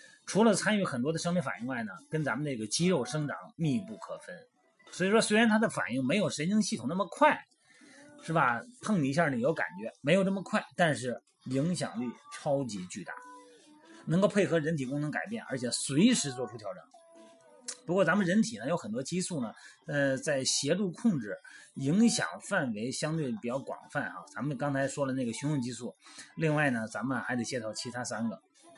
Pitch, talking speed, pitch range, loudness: 190 Hz, 295 characters per minute, 145-240 Hz, -31 LUFS